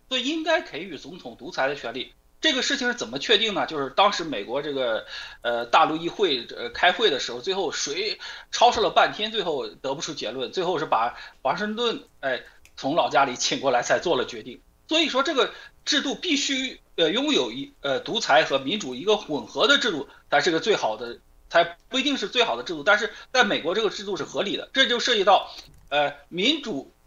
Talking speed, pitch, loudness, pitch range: 310 characters per minute, 270 Hz, -24 LUFS, 210-340 Hz